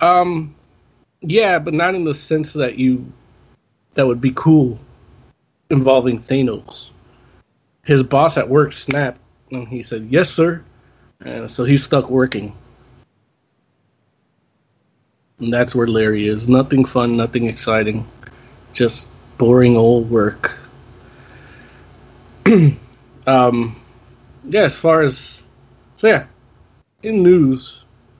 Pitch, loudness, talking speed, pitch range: 125 Hz, -16 LUFS, 110 wpm, 120-145 Hz